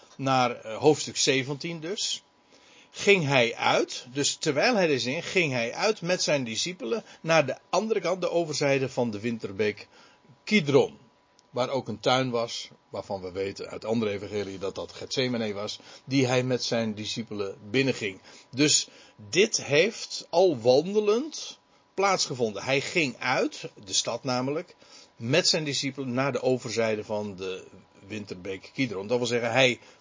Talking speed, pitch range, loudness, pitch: 150 wpm, 115-155 Hz, -26 LUFS, 130 Hz